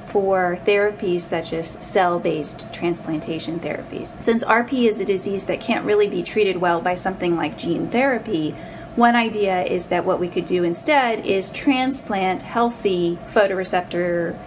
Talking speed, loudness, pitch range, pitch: 155 wpm, -21 LUFS, 175-210 Hz, 185 Hz